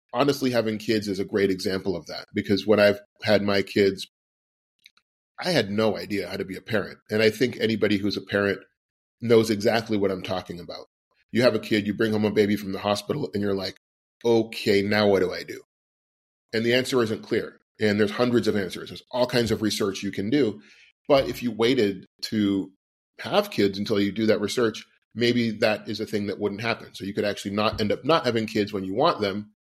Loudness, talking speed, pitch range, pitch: -24 LUFS, 220 wpm, 100-115 Hz, 105 Hz